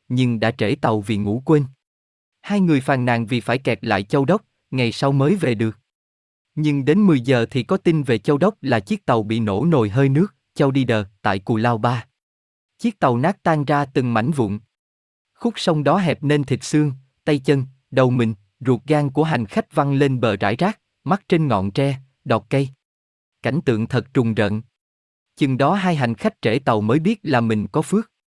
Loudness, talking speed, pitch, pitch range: -20 LUFS, 210 wpm, 135 Hz, 115-155 Hz